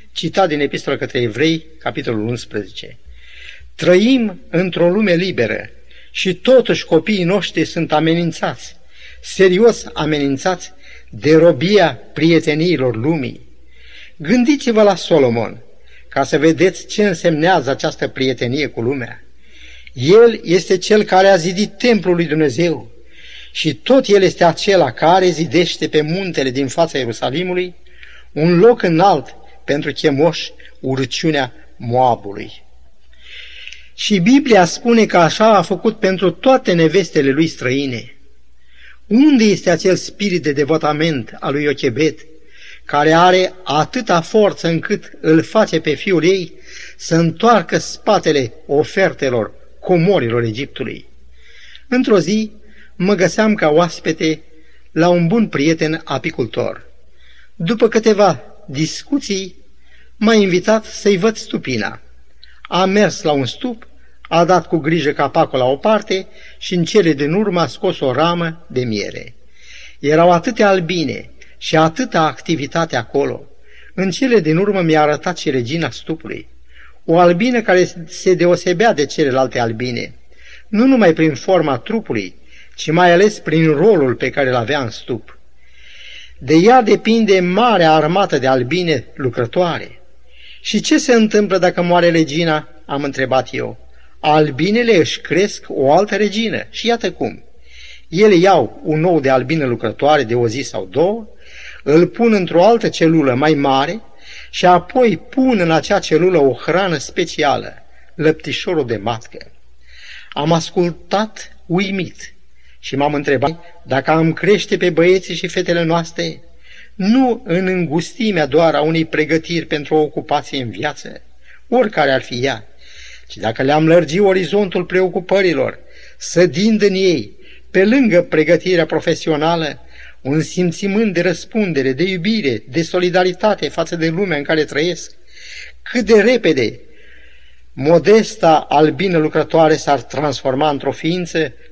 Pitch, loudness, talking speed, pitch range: 165 Hz, -15 LUFS, 130 wpm, 145-190 Hz